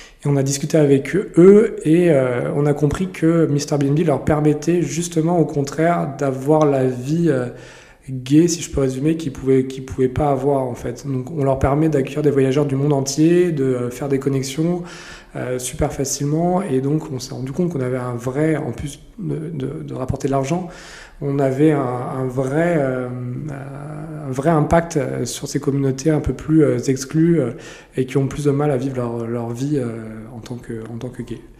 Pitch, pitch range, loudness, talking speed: 140 Hz, 130-155 Hz, -19 LUFS, 200 wpm